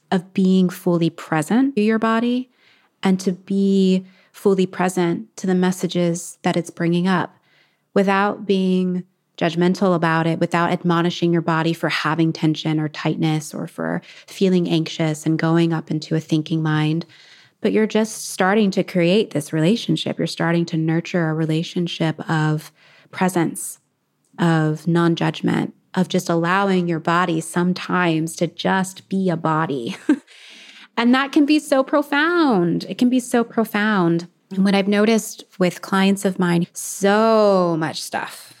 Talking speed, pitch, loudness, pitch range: 150 wpm, 180 Hz, -20 LUFS, 165-195 Hz